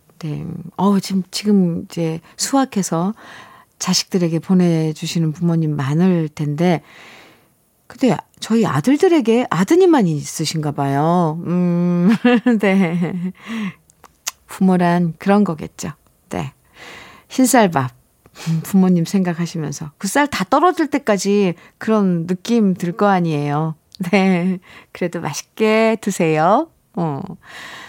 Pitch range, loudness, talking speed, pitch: 165-210 Hz, -17 LUFS, 215 characters per minute, 180 Hz